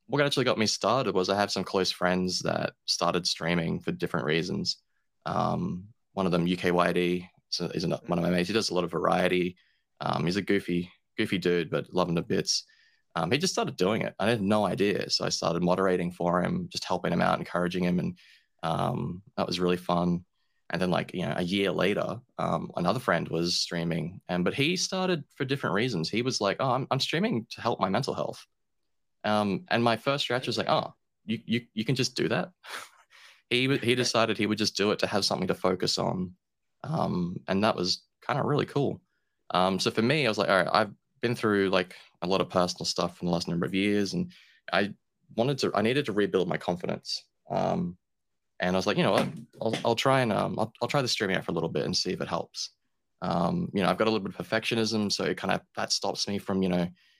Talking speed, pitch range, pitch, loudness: 235 wpm, 90-120 Hz, 100 Hz, -28 LUFS